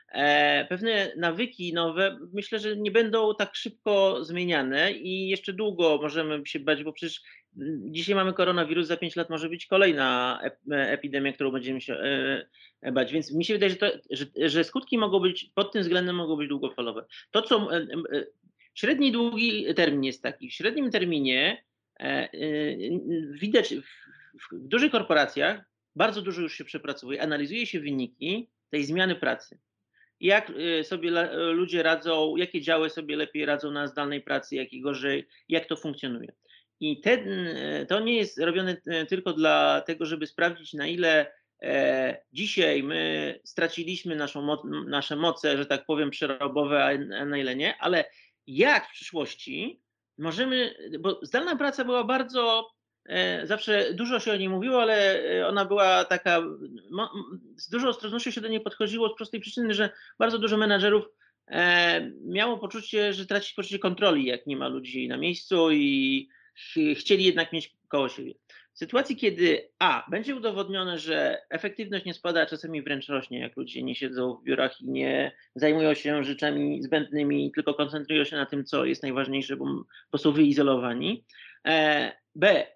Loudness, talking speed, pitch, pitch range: -27 LUFS, 155 wpm, 170 Hz, 145-210 Hz